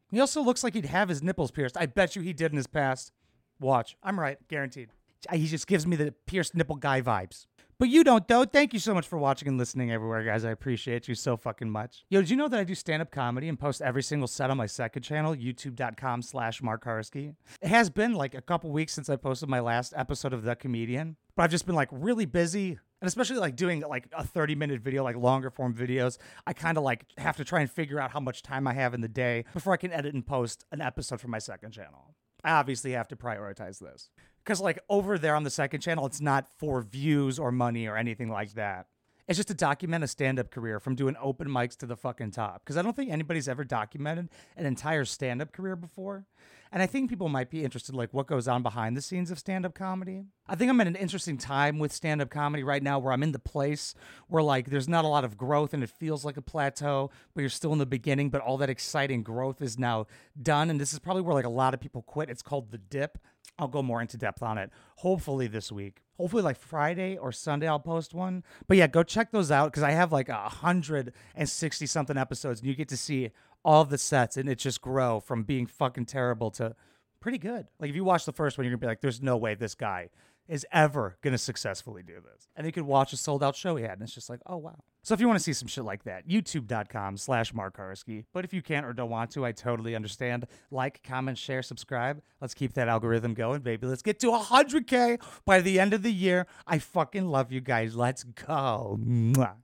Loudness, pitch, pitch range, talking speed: -29 LUFS, 140 Hz, 125-165 Hz, 245 wpm